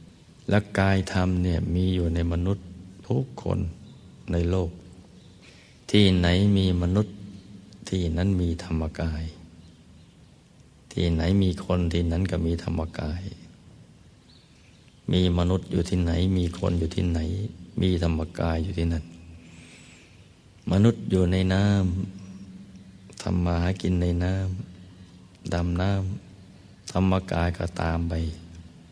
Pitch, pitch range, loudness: 90 Hz, 85-95 Hz, -26 LUFS